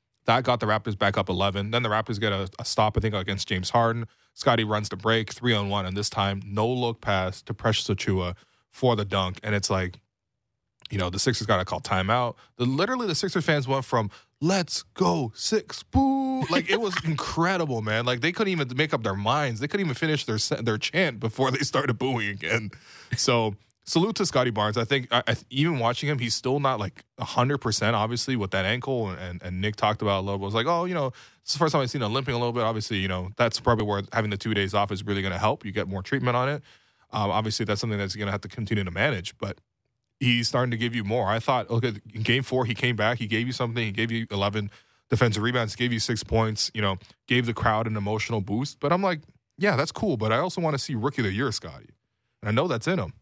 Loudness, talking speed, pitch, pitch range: -26 LUFS, 255 wpm, 115 Hz, 105-130 Hz